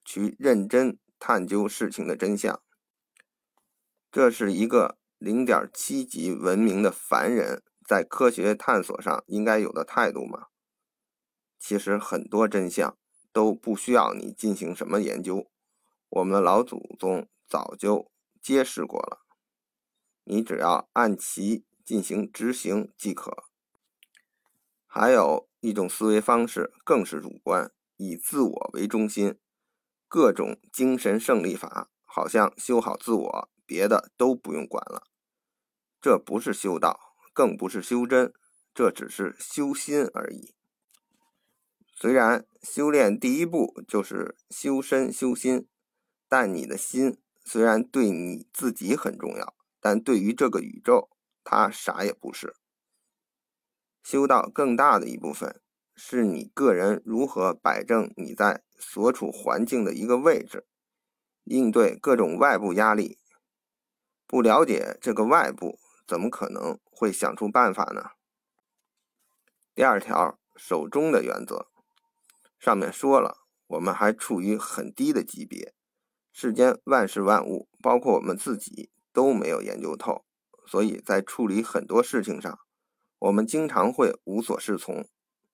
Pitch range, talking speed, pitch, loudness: 110-155 Hz, 195 characters per minute, 125 Hz, -25 LUFS